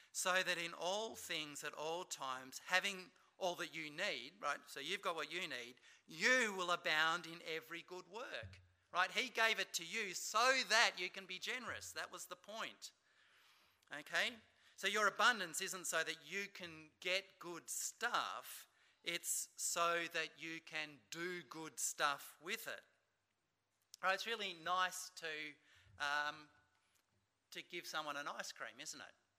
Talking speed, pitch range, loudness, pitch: 160 wpm, 155-185 Hz, -41 LUFS, 170 Hz